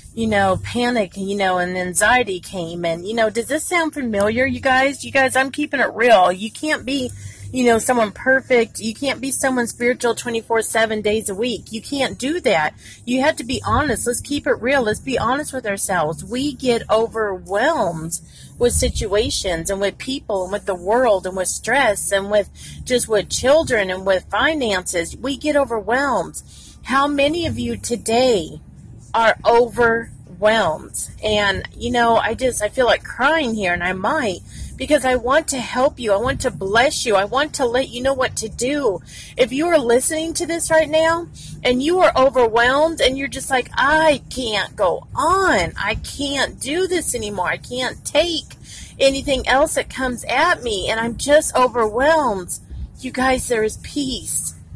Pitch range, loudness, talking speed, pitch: 210-275 Hz, -18 LUFS, 180 wpm, 245 Hz